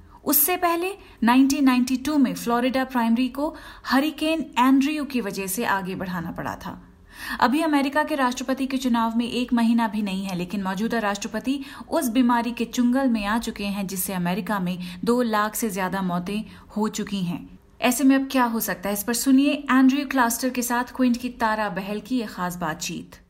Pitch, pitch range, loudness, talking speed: 235 Hz, 205-265 Hz, -23 LUFS, 185 wpm